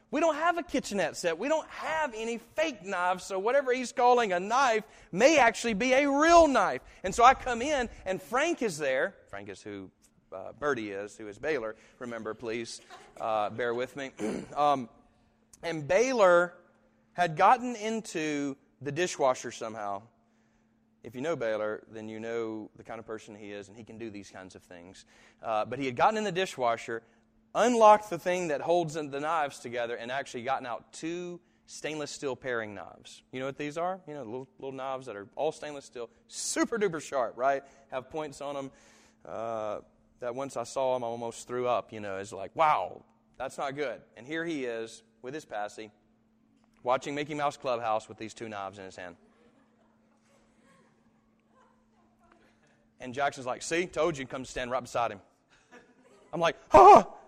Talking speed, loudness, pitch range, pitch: 185 wpm, -29 LUFS, 110-180 Hz, 135 Hz